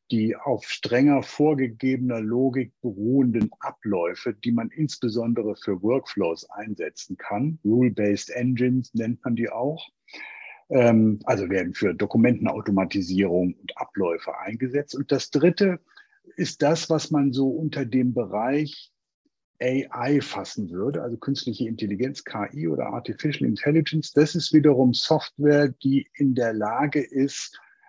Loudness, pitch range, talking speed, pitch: -24 LUFS, 115-150 Hz, 125 wpm, 130 Hz